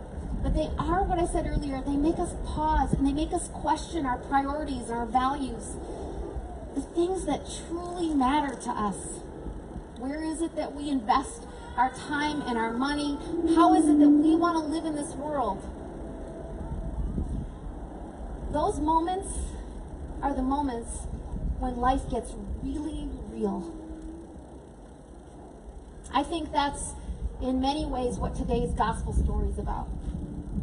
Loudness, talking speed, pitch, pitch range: -29 LUFS, 140 wpm, 275 Hz, 235-310 Hz